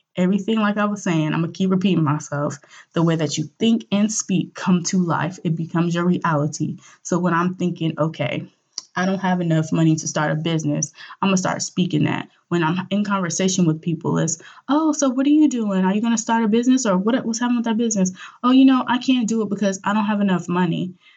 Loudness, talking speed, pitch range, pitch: -20 LUFS, 240 wpm, 165-215 Hz, 185 Hz